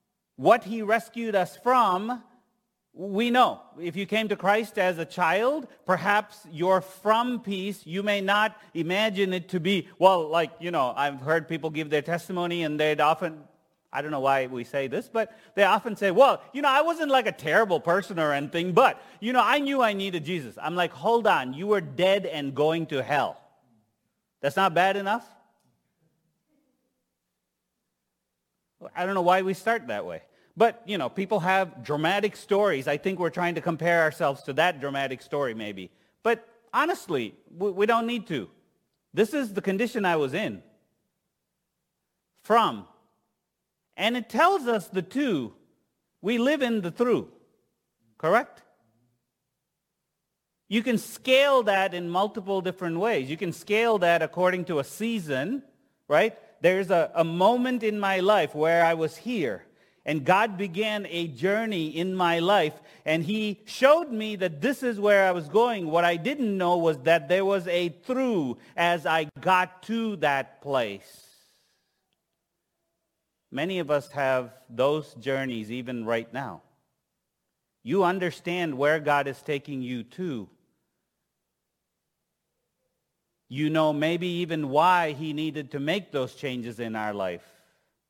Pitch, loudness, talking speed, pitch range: 180 Hz, -26 LUFS, 155 wpm, 155-215 Hz